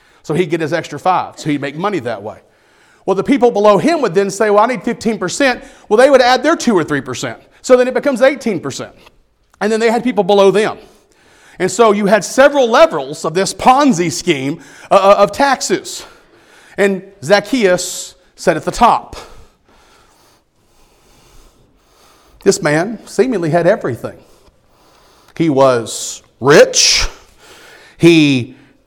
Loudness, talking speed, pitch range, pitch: -13 LUFS, 150 wpm, 175-255 Hz, 205 Hz